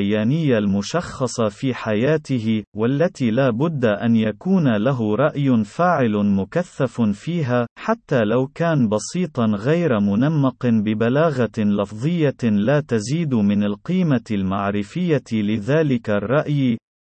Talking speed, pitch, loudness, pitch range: 100 wpm, 120 Hz, -20 LUFS, 105-150 Hz